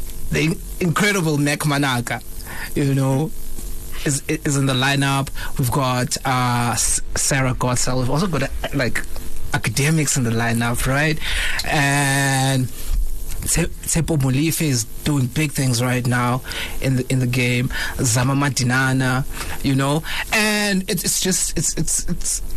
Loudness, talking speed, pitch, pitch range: -20 LUFS, 135 wpm, 135 Hz, 125-150 Hz